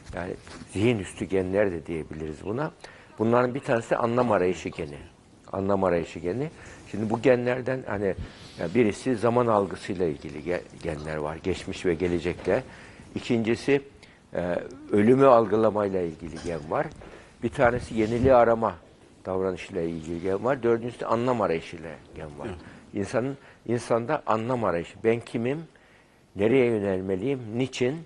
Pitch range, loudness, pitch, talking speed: 90-120 Hz, -26 LUFS, 105 Hz, 130 wpm